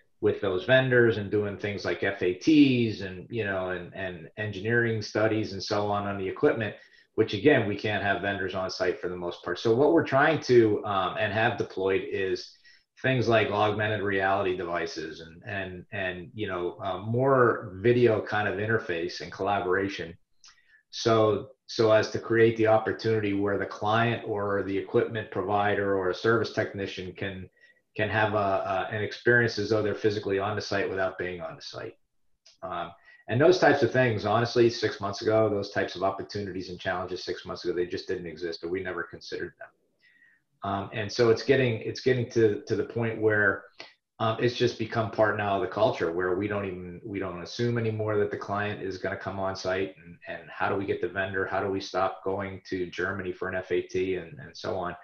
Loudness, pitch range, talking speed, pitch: -27 LUFS, 95-115 Hz, 205 wpm, 105 Hz